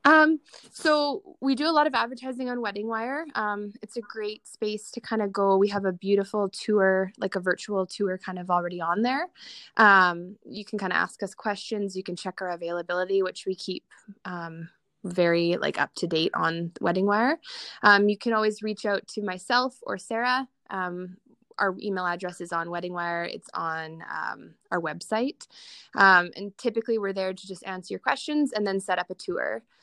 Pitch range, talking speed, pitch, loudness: 185-225 Hz, 190 wpm, 200 Hz, -26 LUFS